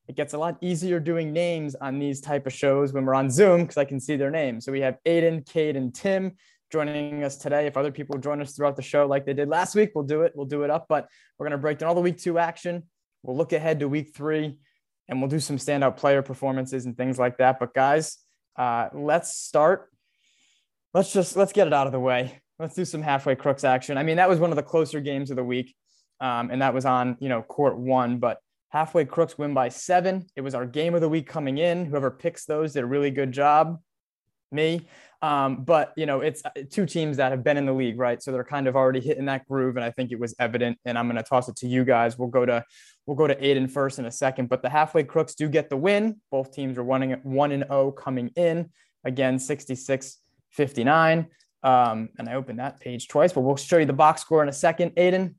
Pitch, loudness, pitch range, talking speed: 140 Hz, -24 LUFS, 130-160 Hz, 250 wpm